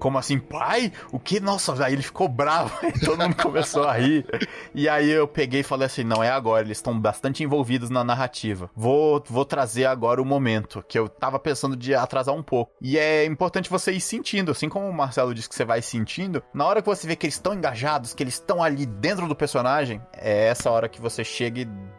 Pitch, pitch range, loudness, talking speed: 140 Hz, 120-155 Hz, -24 LUFS, 225 wpm